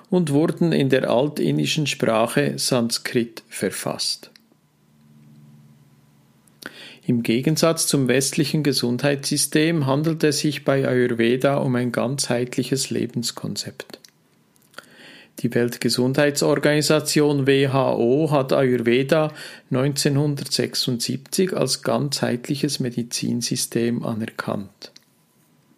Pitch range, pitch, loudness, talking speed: 120-145 Hz, 130 Hz, -21 LUFS, 75 wpm